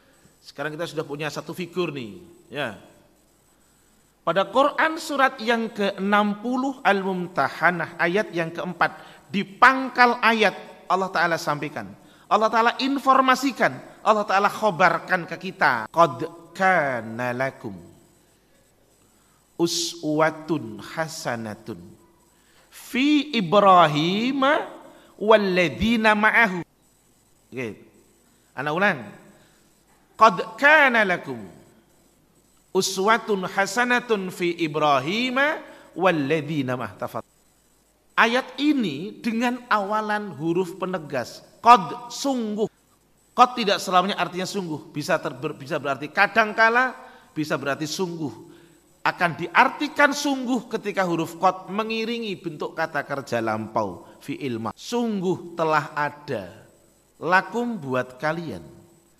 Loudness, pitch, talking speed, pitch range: -22 LUFS, 185 Hz, 95 wpm, 160-230 Hz